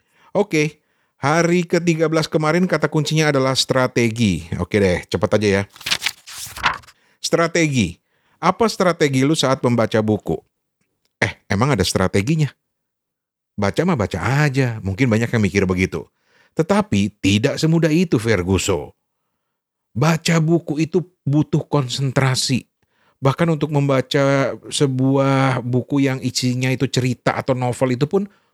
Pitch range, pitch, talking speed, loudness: 115-160 Hz, 135 Hz, 120 wpm, -19 LUFS